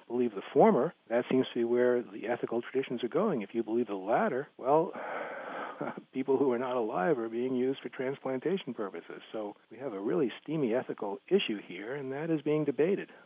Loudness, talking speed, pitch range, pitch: -32 LUFS, 200 wpm, 120-135 Hz, 125 Hz